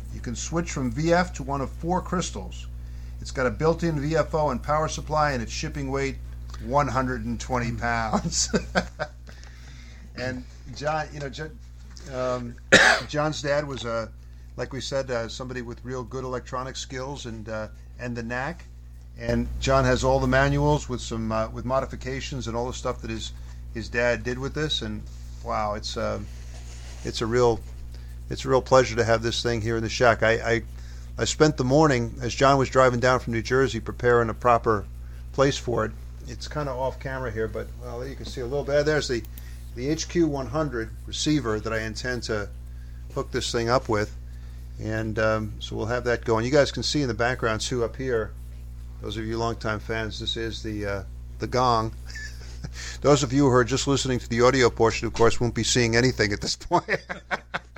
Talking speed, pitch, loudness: 195 wpm, 115 Hz, -25 LUFS